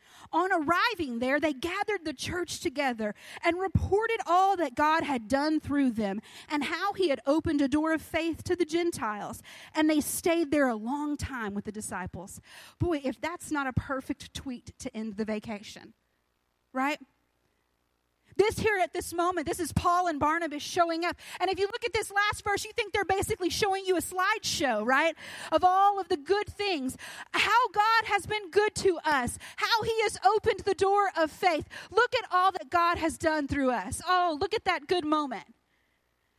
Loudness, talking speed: -28 LUFS, 190 wpm